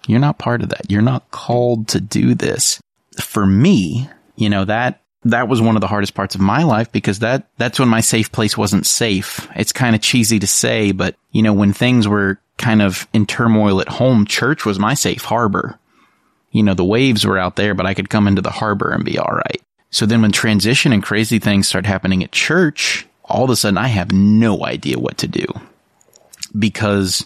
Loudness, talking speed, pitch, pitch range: -15 LUFS, 220 wpm, 105 Hz, 100-115 Hz